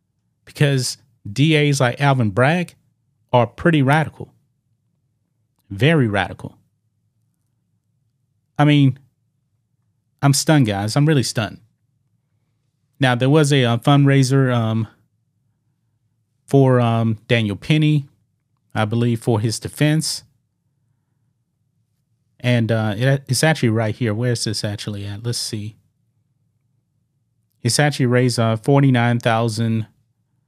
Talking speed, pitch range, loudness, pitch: 105 wpm, 115-135 Hz, -18 LUFS, 125 Hz